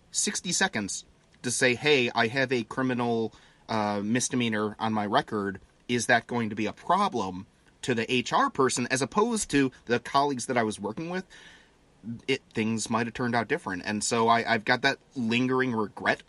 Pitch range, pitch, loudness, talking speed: 110-130 Hz, 120 Hz, -27 LUFS, 185 wpm